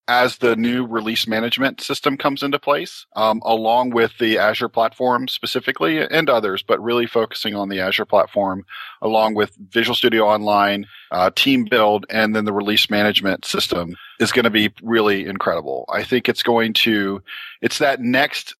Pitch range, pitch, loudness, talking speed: 105-120 Hz, 115 Hz, -18 LUFS, 170 wpm